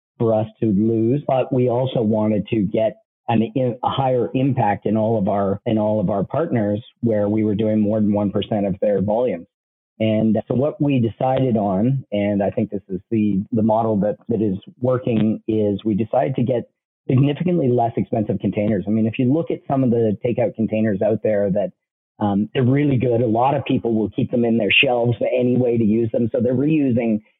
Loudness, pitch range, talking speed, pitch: -20 LUFS, 105-130 Hz, 210 wpm, 115 Hz